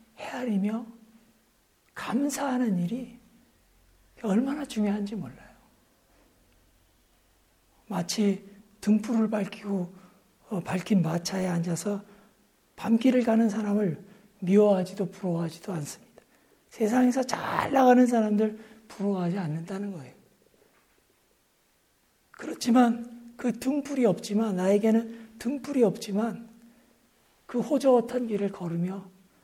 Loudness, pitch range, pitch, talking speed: -27 LUFS, 190-235 Hz, 210 Hz, 230 characters per minute